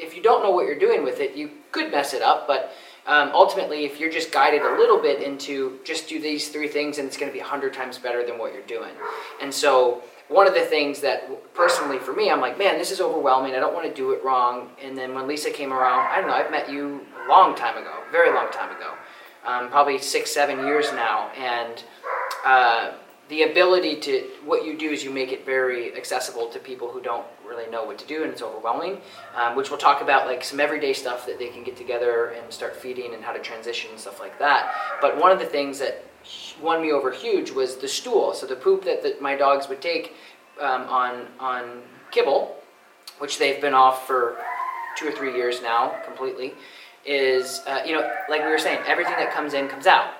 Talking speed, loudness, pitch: 230 wpm, -23 LUFS, 155 Hz